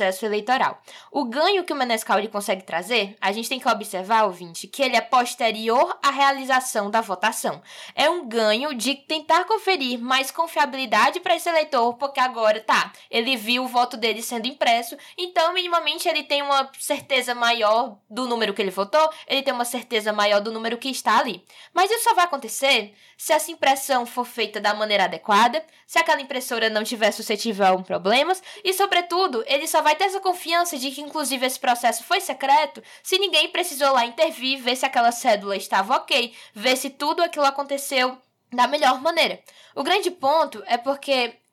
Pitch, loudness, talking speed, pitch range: 260 Hz, -22 LUFS, 185 wpm, 225-310 Hz